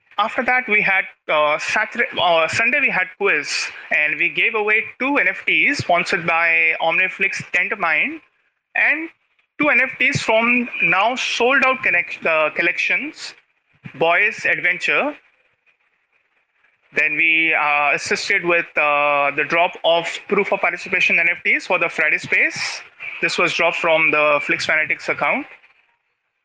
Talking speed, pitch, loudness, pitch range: 130 wpm, 185 Hz, -17 LUFS, 165-230 Hz